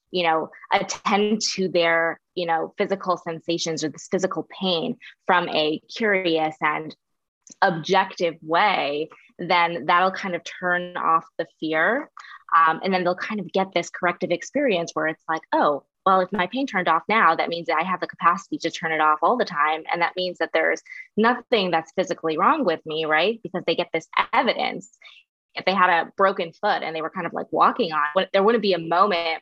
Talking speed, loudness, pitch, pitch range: 200 wpm, -22 LUFS, 175 Hz, 160-190 Hz